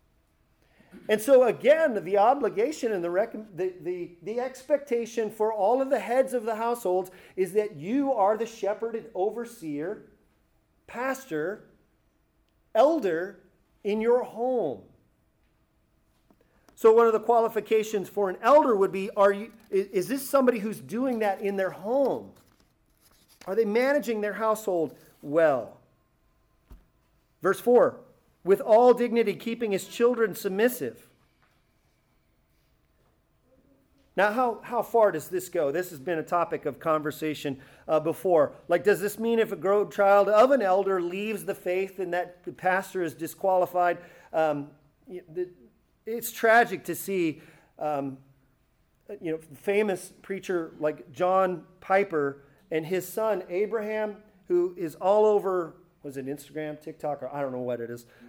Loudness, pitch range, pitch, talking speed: -26 LUFS, 170-225 Hz, 195 Hz, 140 wpm